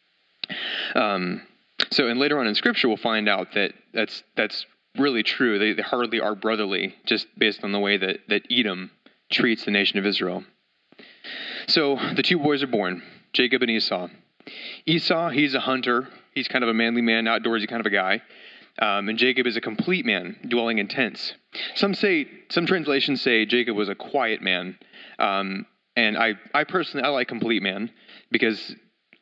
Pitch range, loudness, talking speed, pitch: 105-140 Hz, -23 LUFS, 180 wpm, 120 Hz